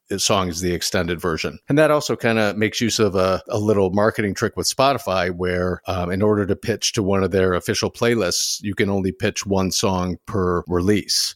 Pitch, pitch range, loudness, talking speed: 100 Hz, 90-110 Hz, -20 LUFS, 210 wpm